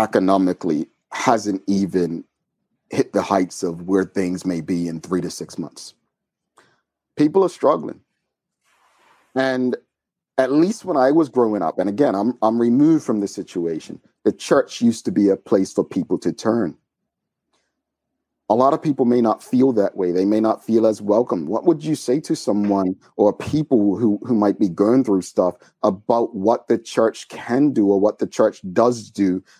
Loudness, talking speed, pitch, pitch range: -20 LUFS, 180 wpm, 110 Hz, 95-130 Hz